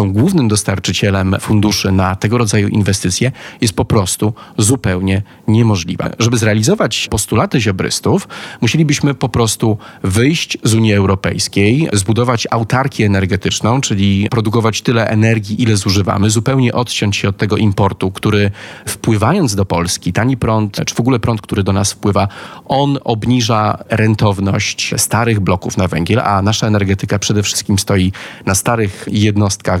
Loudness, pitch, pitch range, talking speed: -14 LUFS, 105 Hz, 100-120 Hz, 135 wpm